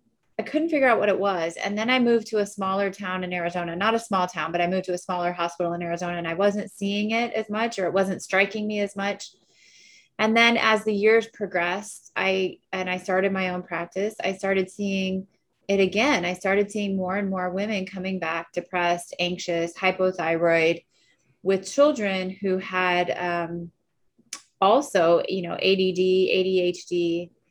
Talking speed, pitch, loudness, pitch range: 185 wpm, 190 Hz, -24 LUFS, 175-205 Hz